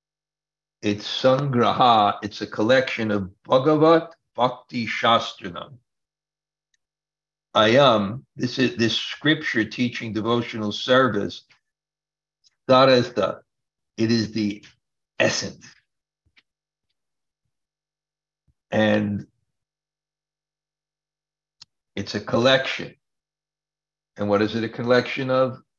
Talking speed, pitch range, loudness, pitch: 75 wpm, 110-155 Hz, -21 LUFS, 125 Hz